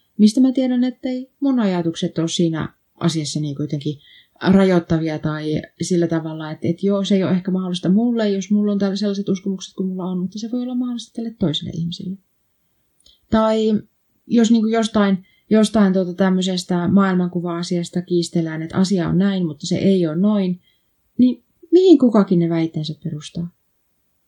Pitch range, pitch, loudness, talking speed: 170-210 Hz, 185 Hz, -19 LUFS, 165 wpm